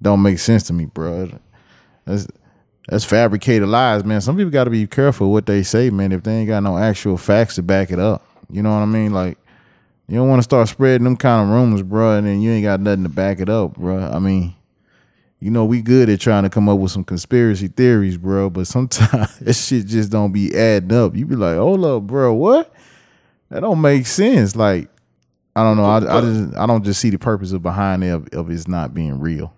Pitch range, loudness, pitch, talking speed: 95-115 Hz, -16 LUFS, 105 Hz, 235 wpm